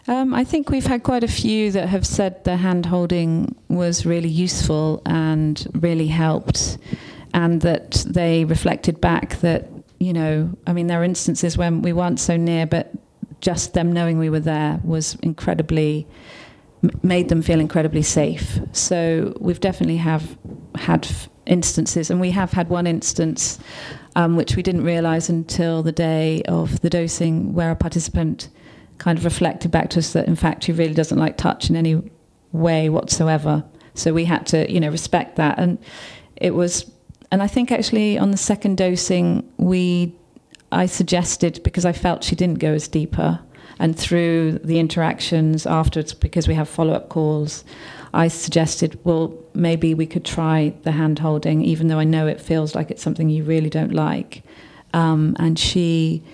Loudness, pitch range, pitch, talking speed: -20 LUFS, 160-175 Hz, 165 Hz, 175 wpm